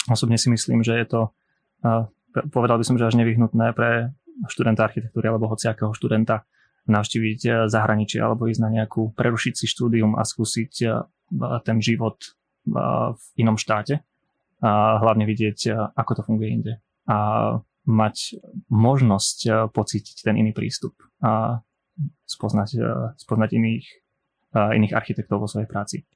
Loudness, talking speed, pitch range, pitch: -22 LUFS, 130 wpm, 110-120 Hz, 115 Hz